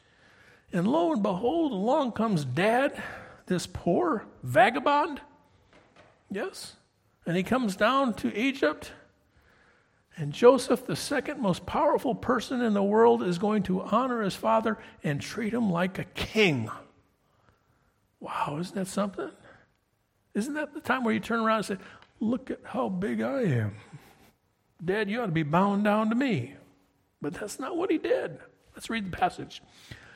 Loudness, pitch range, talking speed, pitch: -28 LUFS, 190-250 Hz, 155 wpm, 220 Hz